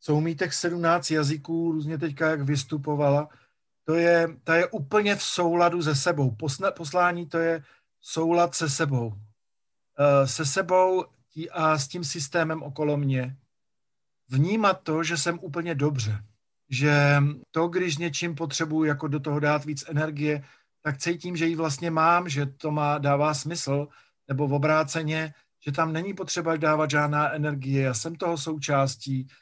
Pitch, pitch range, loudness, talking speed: 155 Hz, 145-170 Hz, -25 LUFS, 150 wpm